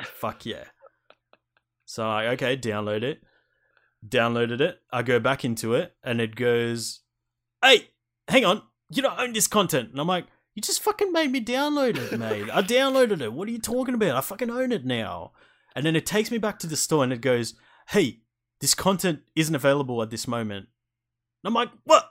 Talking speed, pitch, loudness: 200 wpm, 140 Hz, -24 LUFS